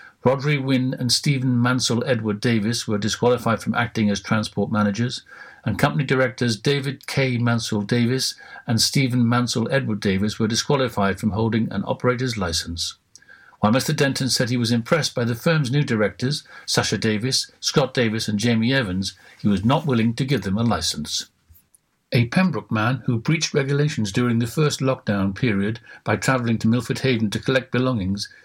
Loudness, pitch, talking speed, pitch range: -21 LUFS, 120 Hz, 170 wpm, 110-130 Hz